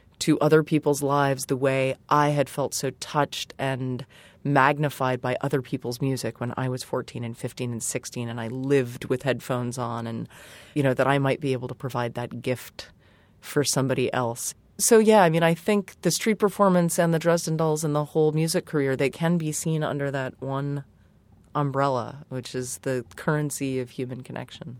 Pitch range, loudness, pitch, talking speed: 125-150 Hz, -25 LUFS, 135 Hz, 190 wpm